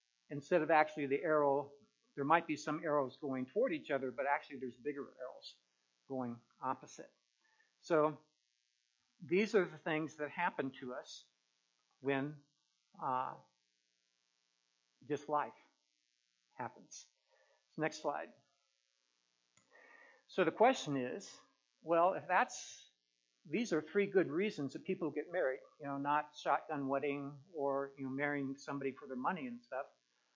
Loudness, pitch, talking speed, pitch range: -38 LUFS, 140 Hz, 130 wpm, 120-155 Hz